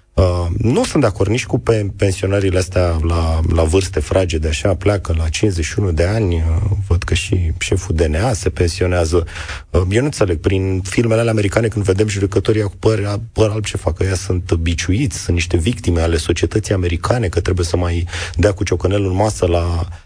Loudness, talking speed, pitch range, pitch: -17 LUFS, 195 wpm, 85-105 Hz, 95 Hz